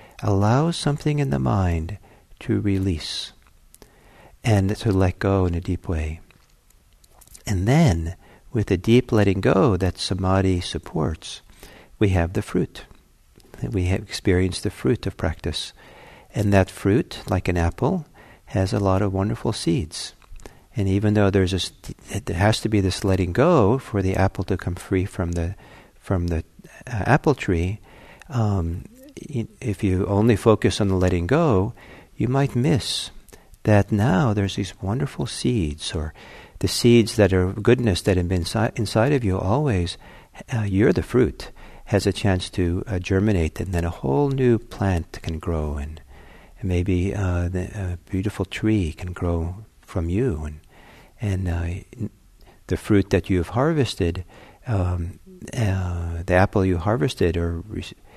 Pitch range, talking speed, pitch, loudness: 90-110 Hz, 155 wpm, 95 Hz, -22 LUFS